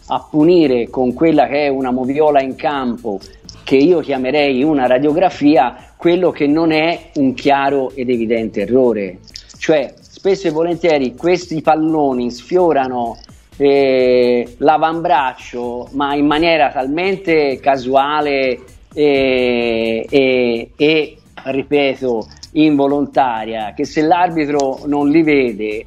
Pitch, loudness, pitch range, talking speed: 140 Hz, -15 LUFS, 125-155 Hz, 115 wpm